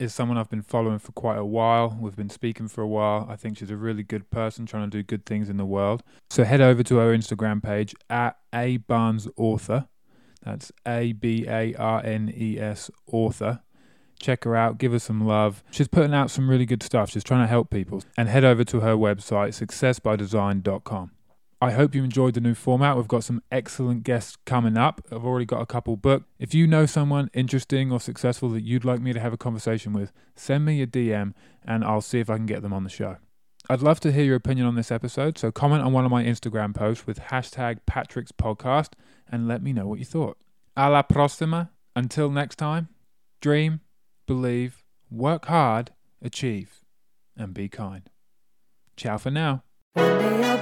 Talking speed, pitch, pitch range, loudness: 205 wpm, 120 Hz, 110-130 Hz, -24 LUFS